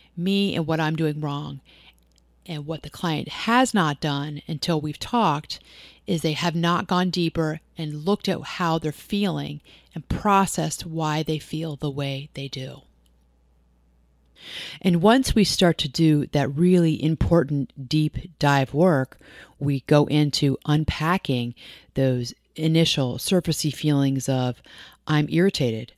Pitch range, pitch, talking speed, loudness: 135-170 Hz, 150 Hz, 140 wpm, -23 LUFS